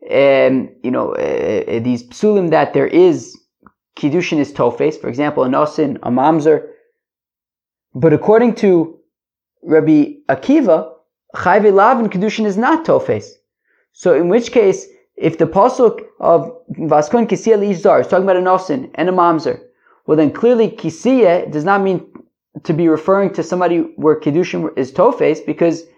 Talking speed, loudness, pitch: 160 wpm, -14 LUFS, 190 Hz